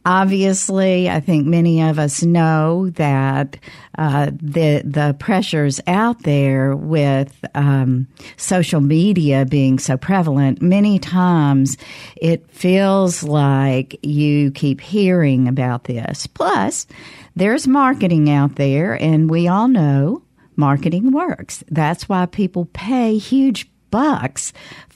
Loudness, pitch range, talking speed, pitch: -16 LUFS, 140-185 Hz, 120 wpm, 155 Hz